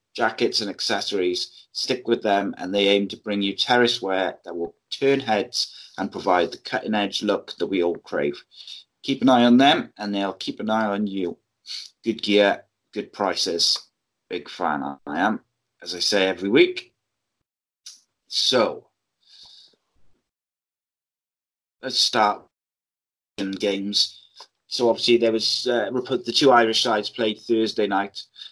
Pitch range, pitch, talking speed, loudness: 100-120 Hz, 110 Hz, 145 wpm, -22 LUFS